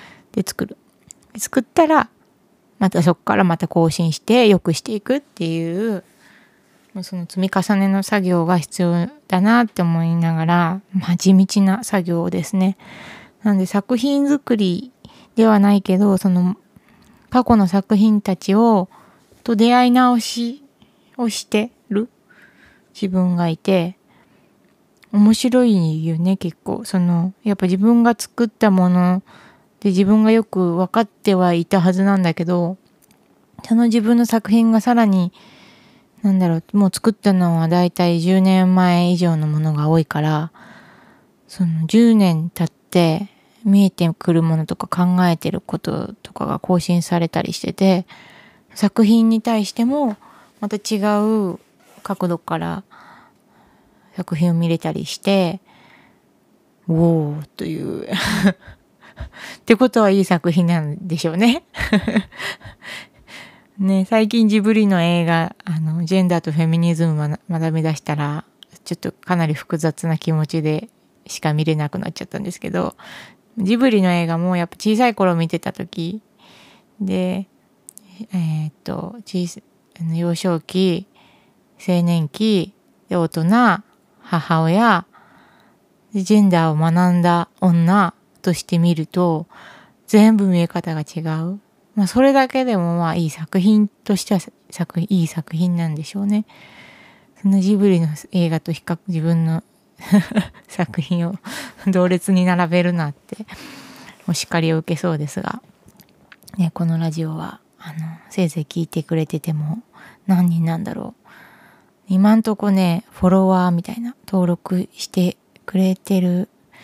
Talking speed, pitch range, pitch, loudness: 255 characters per minute, 170-210 Hz, 185 Hz, -18 LUFS